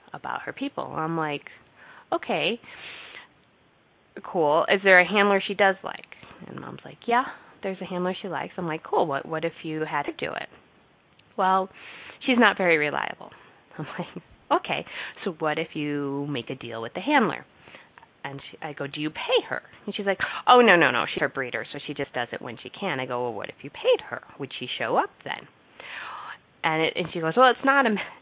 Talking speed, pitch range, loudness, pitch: 215 wpm, 145-205 Hz, -25 LUFS, 170 Hz